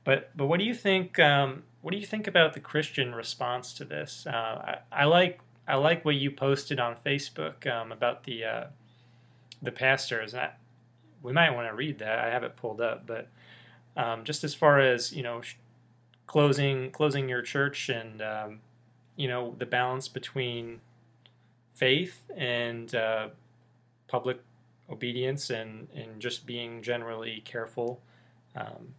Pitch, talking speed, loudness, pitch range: 125 Hz, 160 wpm, -29 LUFS, 120-140 Hz